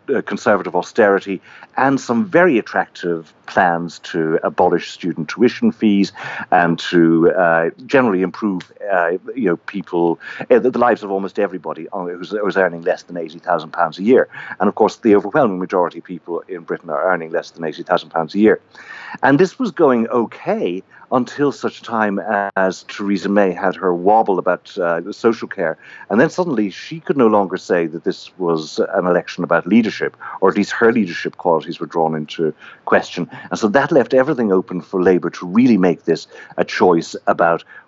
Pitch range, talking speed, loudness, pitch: 90-115 Hz, 180 wpm, -17 LUFS, 100 Hz